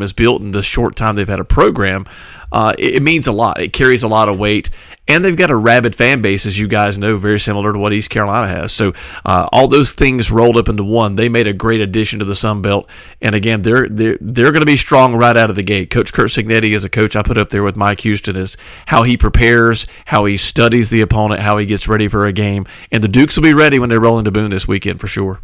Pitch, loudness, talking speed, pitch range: 110 Hz, -12 LUFS, 275 wpm, 105-120 Hz